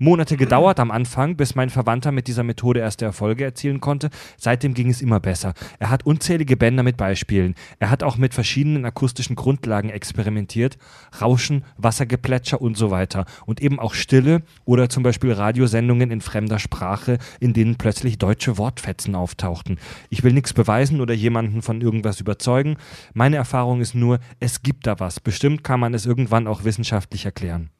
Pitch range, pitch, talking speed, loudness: 110-130 Hz, 120 Hz, 175 wpm, -20 LUFS